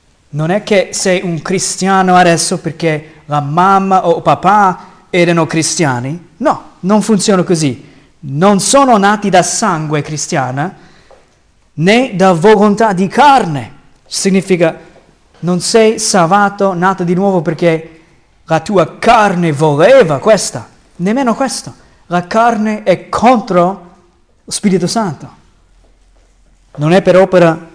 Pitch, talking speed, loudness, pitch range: 180 Hz, 120 wpm, -11 LUFS, 165-205 Hz